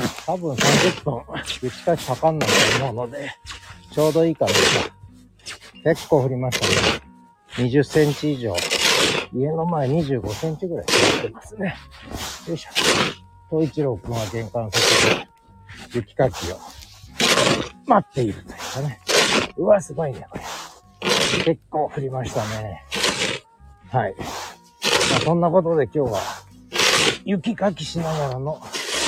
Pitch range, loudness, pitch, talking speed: 105-160 Hz, -21 LUFS, 130 Hz, 245 characters per minute